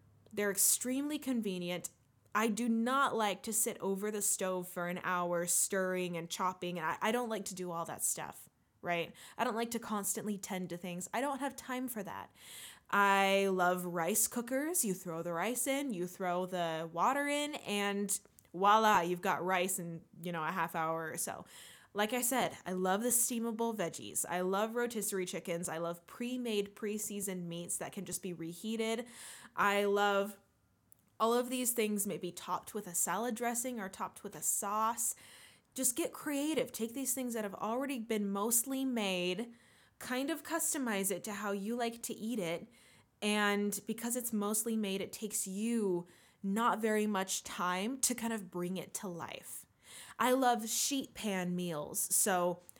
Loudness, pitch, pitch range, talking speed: -35 LUFS, 205 Hz, 180-235 Hz, 175 wpm